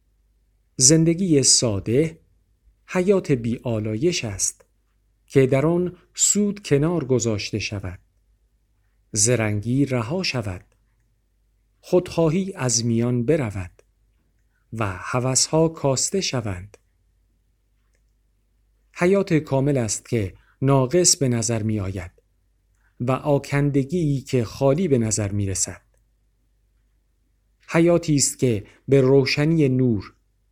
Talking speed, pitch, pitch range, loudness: 90 wpm, 115 Hz, 100-140 Hz, -21 LUFS